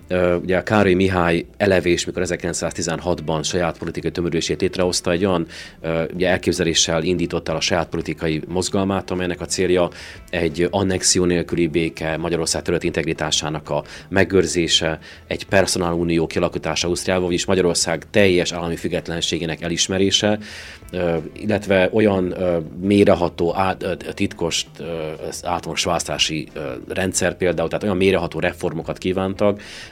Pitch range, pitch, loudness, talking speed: 80-95 Hz, 85 Hz, -20 LUFS, 115 wpm